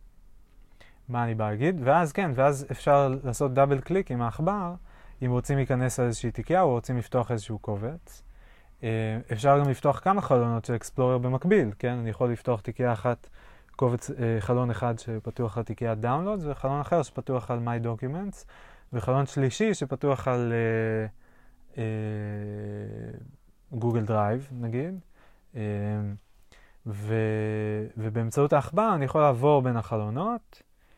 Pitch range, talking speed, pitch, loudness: 110-140 Hz, 135 wpm, 120 Hz, -27 LUFS